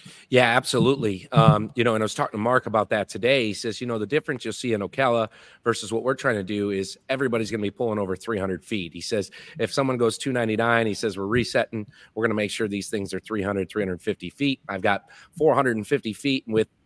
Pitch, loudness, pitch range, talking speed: 110 Hz, -24 LUFS, 100-125 Hz, 230 wpm